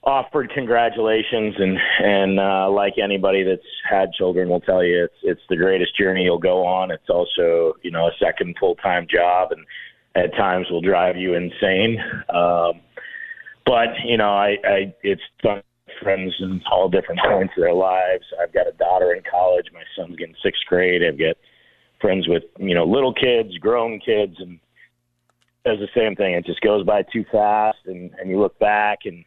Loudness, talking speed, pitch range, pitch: -19 LUFS, 185 wpm, 90-110 Hz, 95 Hz